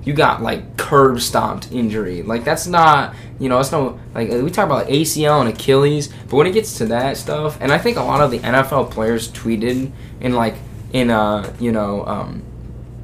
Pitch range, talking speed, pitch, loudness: 115-140 Hz, 205 wpm, 125 Hz, -17 LUFS